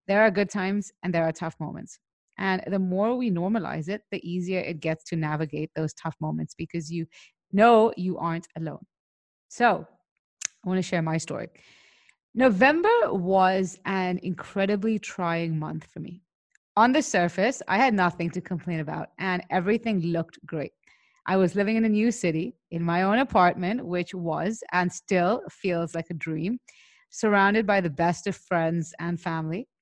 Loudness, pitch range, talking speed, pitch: -26 LUFS, 170-205 Hz, 170 wpm, 180 Hz